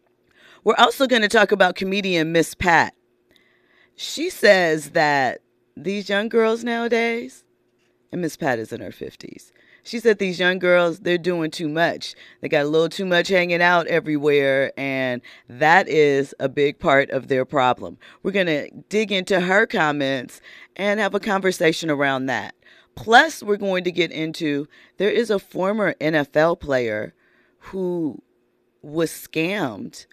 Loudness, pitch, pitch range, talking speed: -20 LUFS, 175 Hz, 150-200 Hz, 150 wpm